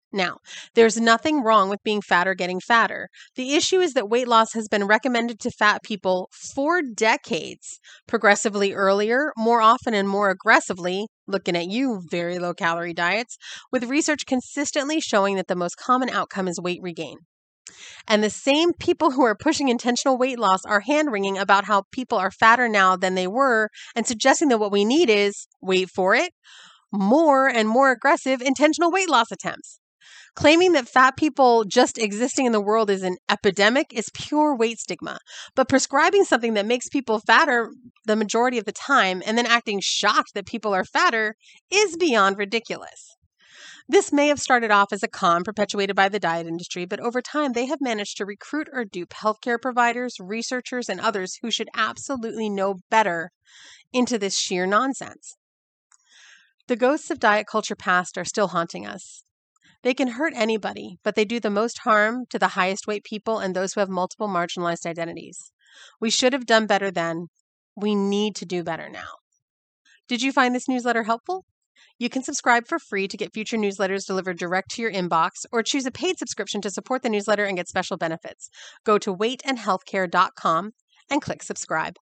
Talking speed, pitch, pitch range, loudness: 180 wpm, 220 Hz, 195-255 Hz, -22 LUFS